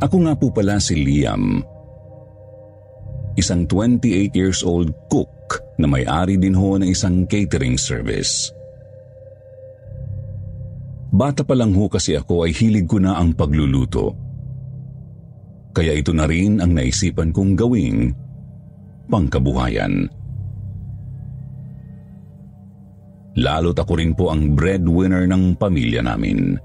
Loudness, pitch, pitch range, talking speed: -18 LUFS, 100 Hz, 90-120 Hz, 110 wpm